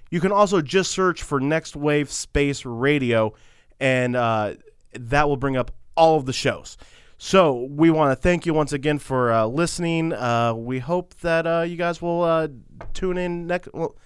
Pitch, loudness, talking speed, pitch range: 150 Hz, -22 LUFS, 190 wpm, 130-170 Hz